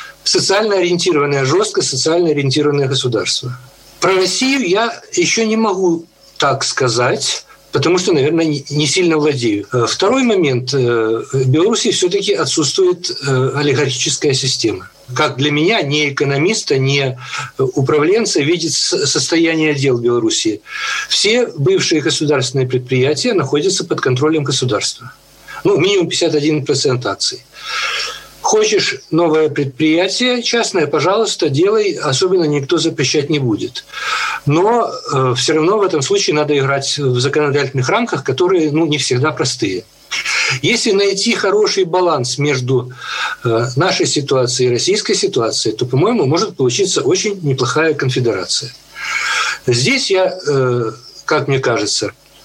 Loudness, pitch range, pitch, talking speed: -15 LUFS, 135-210 Hz, 155 Hz, 115 wpm